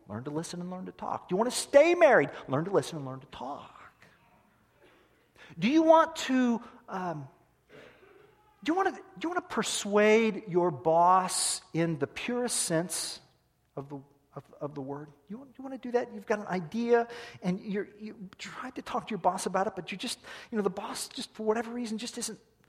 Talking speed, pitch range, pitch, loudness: 215 wpm, 170-245 Hz, 210 Hz, -29 LUFS